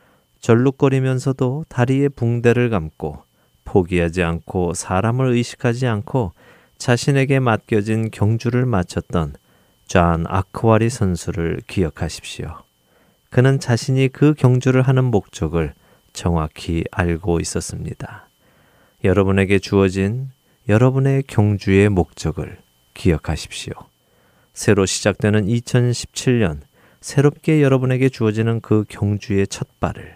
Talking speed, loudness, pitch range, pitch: 260 characters per minute, -19 LUFS, 90-130 Hz, 110 Hz